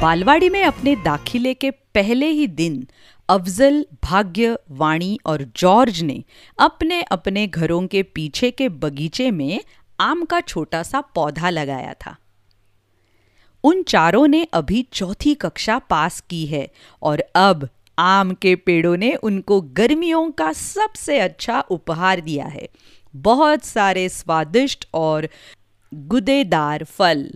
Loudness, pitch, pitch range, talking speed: -18 LUFS, 185 Hz, 155-255 Hz, 125 wpm